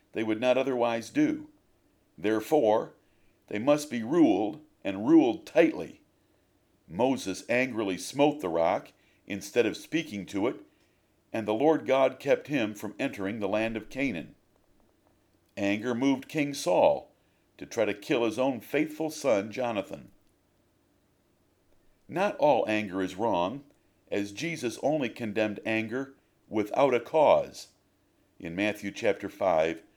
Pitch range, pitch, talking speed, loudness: 105-150 Hz, 120 Hz, 130 wpm, -28 LUFS